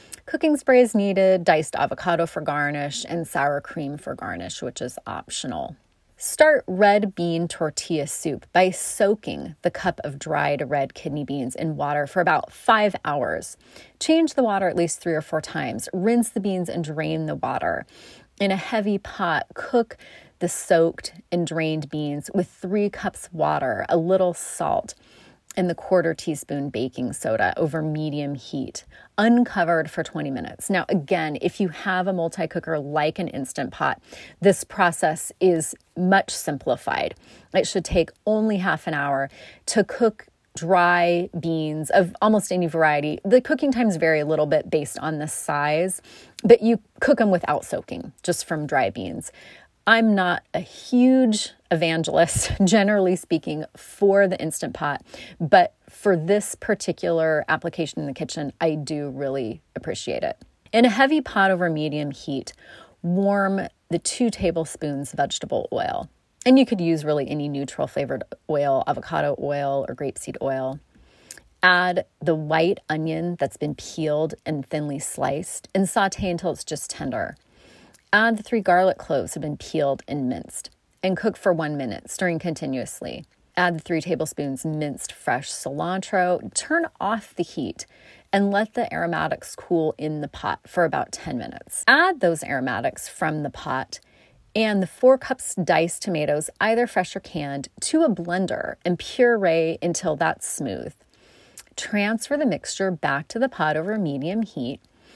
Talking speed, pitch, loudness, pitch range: 155 wpm, 175 Hz, -23 LUFS, 155-200 Hz